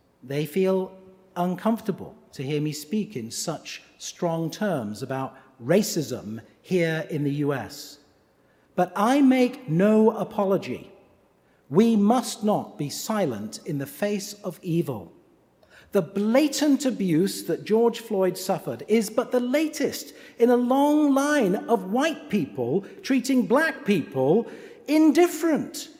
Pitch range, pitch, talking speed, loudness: 155-245 Hz, 200 Hz, 125 wpm, -24 LUFS